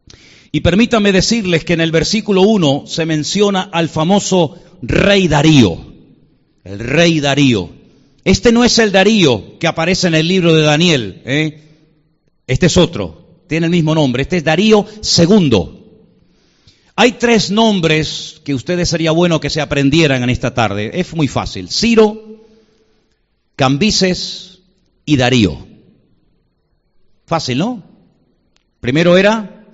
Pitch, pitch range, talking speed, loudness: 170 Hz, 150-195 Hz, 135 wpm, -13 LUFS